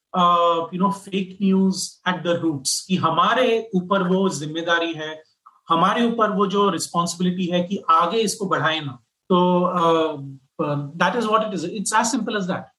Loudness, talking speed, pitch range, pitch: -21 LUFS, 170 wpm, 165-200 Hz, 180 Hz